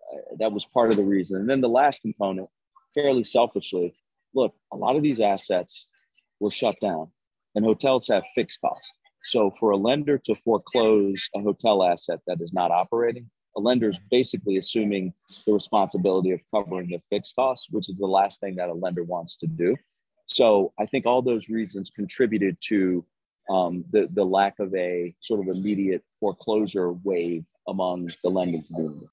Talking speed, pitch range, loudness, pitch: 175 wpm, 90-110 Hz, -25 LUFS, 100 Hz